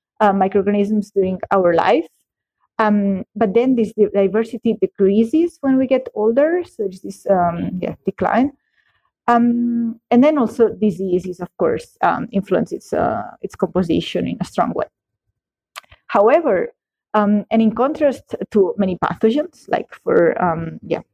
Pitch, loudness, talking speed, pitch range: 220 Hz, -18 LUFS, 140 wpm, 195-255 Hz